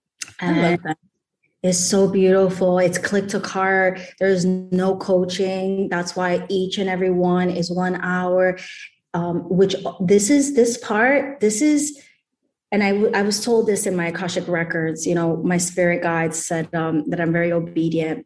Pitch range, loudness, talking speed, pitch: 175-195 Hz, -20 LUFS, 170 wpm, 185 Hz